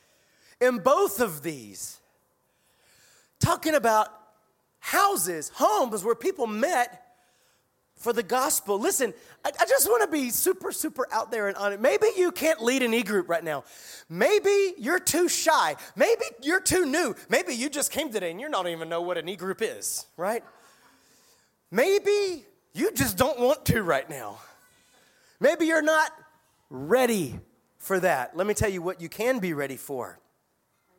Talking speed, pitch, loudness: 165 wpm, 250 Hz, -25 LUFS